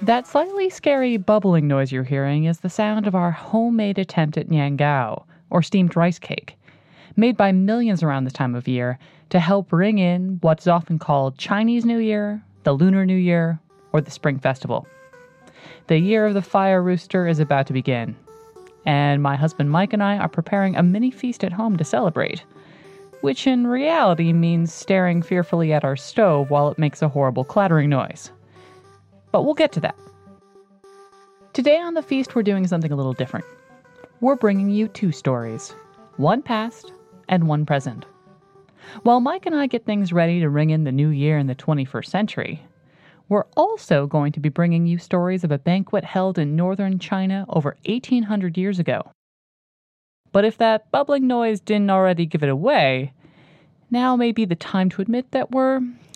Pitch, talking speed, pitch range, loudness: 185 Hz, 180 wpm, 155-215 Hz, -20 LUFS